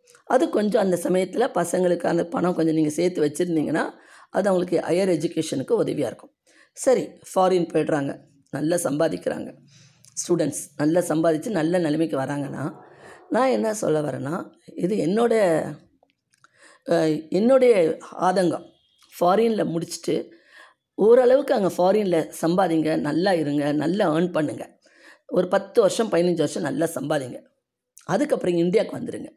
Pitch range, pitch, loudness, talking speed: 155-195 Hz, 170 Hz, -22 LUFS, 115 wpm